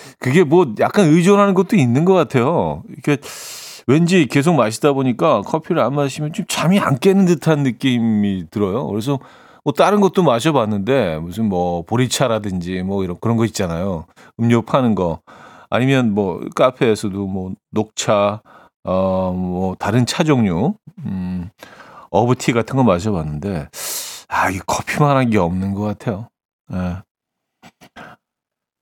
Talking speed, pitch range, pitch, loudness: 275 characters per minute, 100-155 Hz, 125 Hz, -17 LUFS